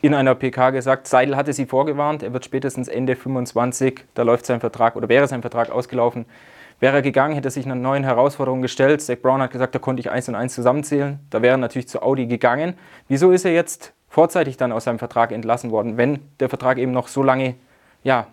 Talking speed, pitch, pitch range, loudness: 225 wpm, 130 Hz, 125-135 Hz, -20 LUFS